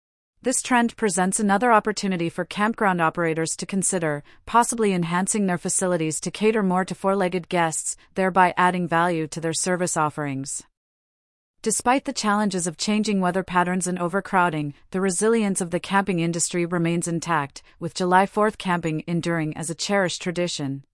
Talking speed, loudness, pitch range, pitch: 155 wpm, -23 LUFS, 170-200 Hz, 180 Hz